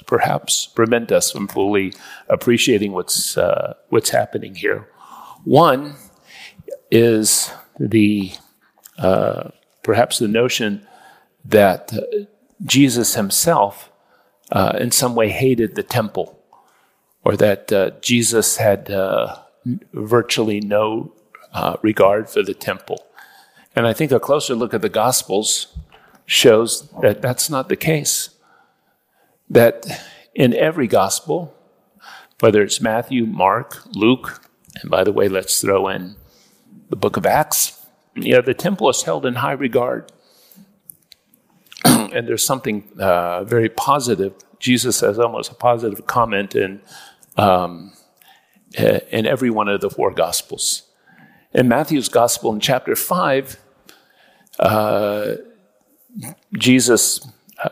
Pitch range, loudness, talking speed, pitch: 105-135 Hz, -17 LUFS, 120 wpm, 115 Hz